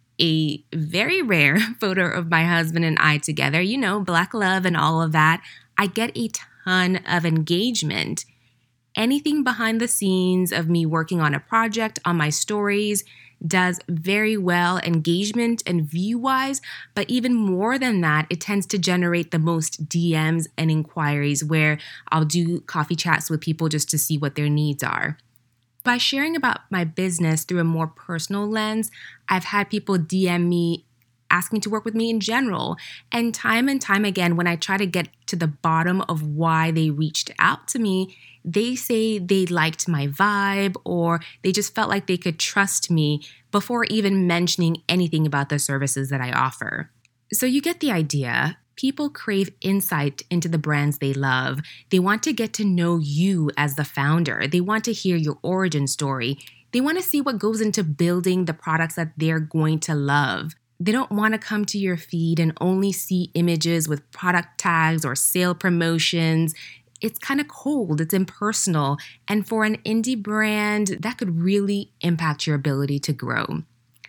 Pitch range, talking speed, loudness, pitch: 155-205 Hz, 180 wpm, -22 LUFS, 175 Hz